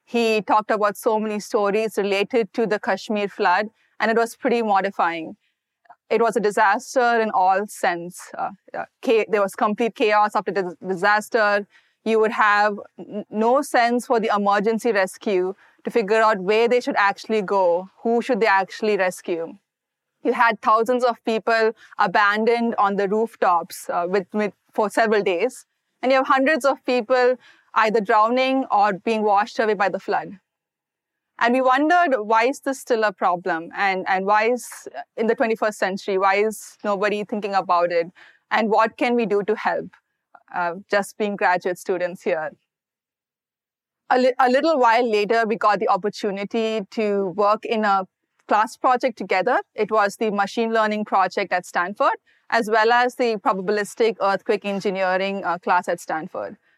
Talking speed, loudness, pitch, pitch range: 165 wpm, -21 LUFS, 215 Hz, 200-235 Hz